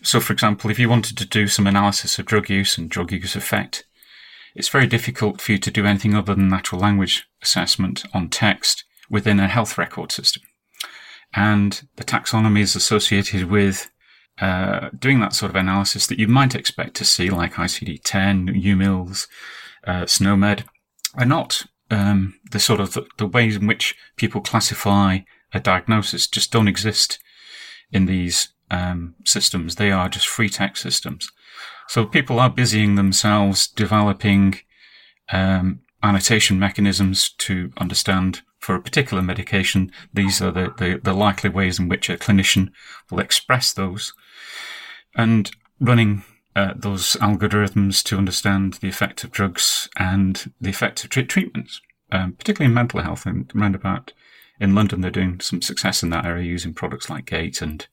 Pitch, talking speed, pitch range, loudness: 100 Hz, 160 wpm, 95-110 Hz, -19 LUFS